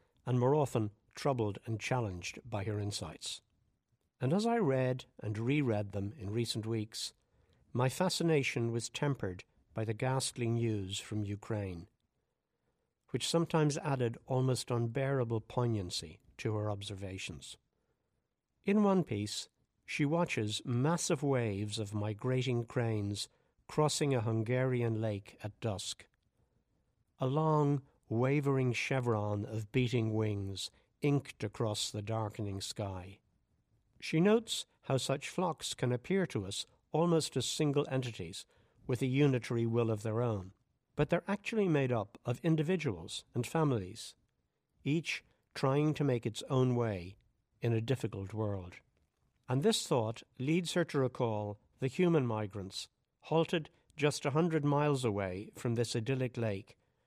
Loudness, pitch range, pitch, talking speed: -35 LUFS, 105-140 Hz, 120 Hz, 130 wpm